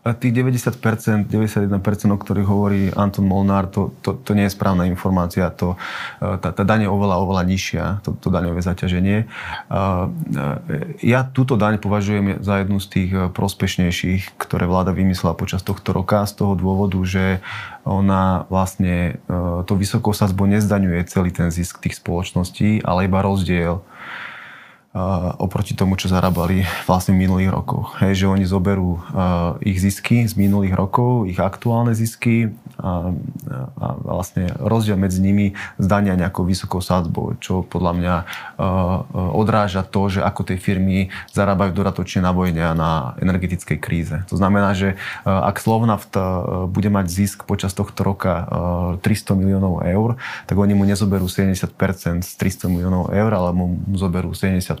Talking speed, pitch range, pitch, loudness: 145 wpm, 90-100 Hz, 95 Hz, -19 LUFS